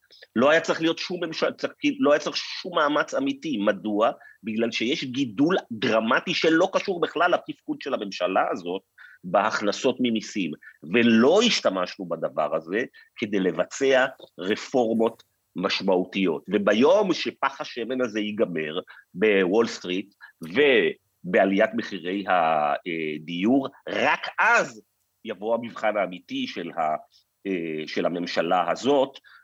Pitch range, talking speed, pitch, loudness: 100-170 Hz, 105 wpm, 115 Hz, -24 LUFS